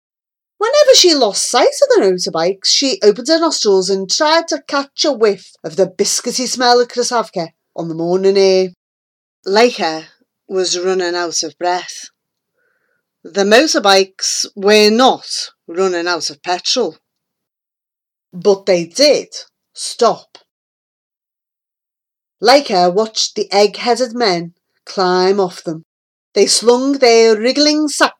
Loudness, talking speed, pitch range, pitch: -13 LUFS, 125 wpm, 180-260 Hz, 205 Hz